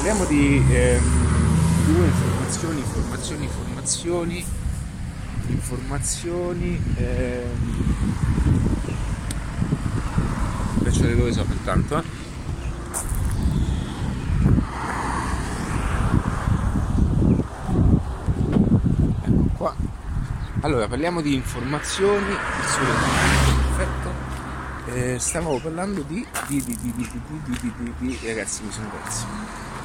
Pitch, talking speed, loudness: 120 Hz, 75 wpm, -23 LUFS